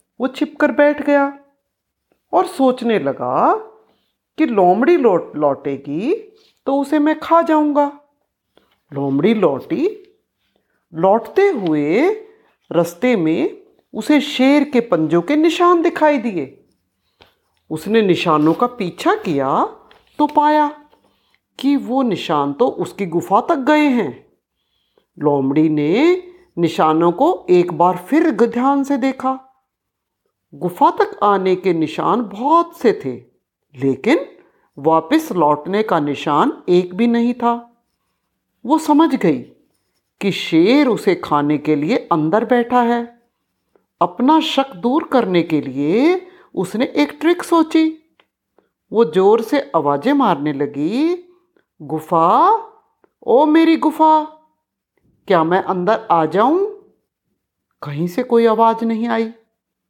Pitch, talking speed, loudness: 245 Hz, 115 wpm, -16 LUFS